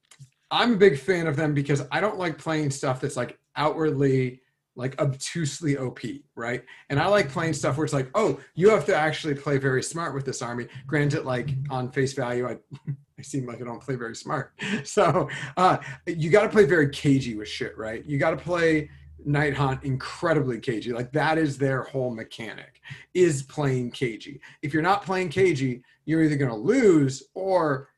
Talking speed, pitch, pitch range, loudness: 195 wpm, 145 Hz, 130-160 Hz, -25 LUFS